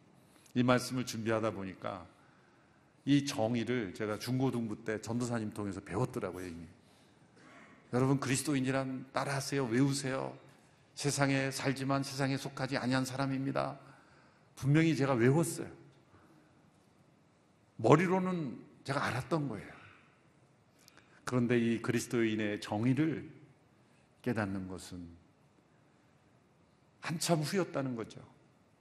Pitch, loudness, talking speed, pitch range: 130 Hz, -34 LUFS, 255 characters per minute, 110-140 Hz